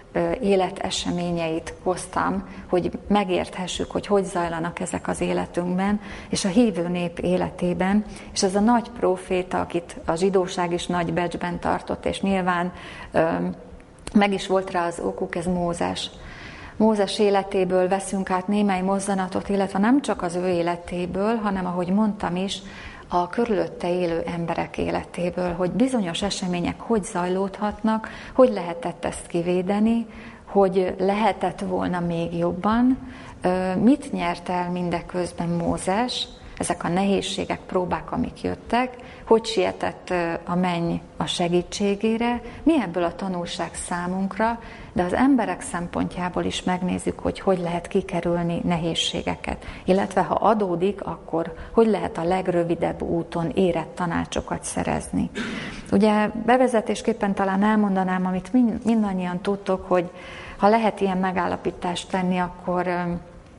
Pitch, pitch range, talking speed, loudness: 185 Hz, 175-205 Hz, 125 wpm, -24 LUFS